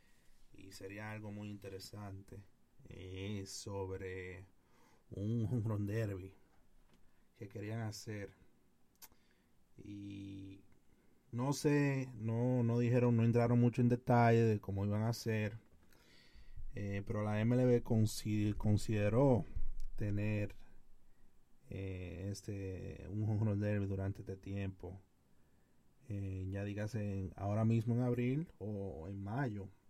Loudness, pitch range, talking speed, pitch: -37 LUFS, 95-115 Hz, 105 wpm, 105 Hz